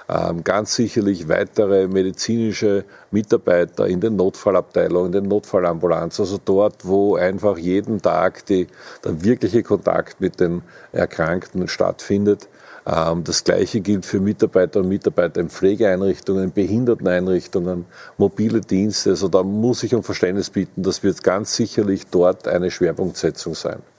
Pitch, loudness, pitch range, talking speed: 100 Hz, -19 LUFS, 90-105 Hz, 130 wpm